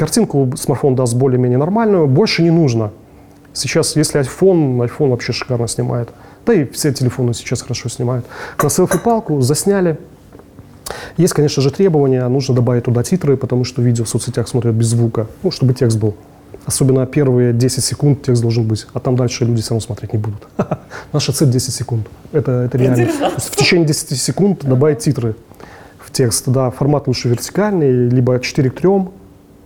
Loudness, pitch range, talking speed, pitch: -15 LUFS, 120-145 Hz, 170 wpm, 130 Hz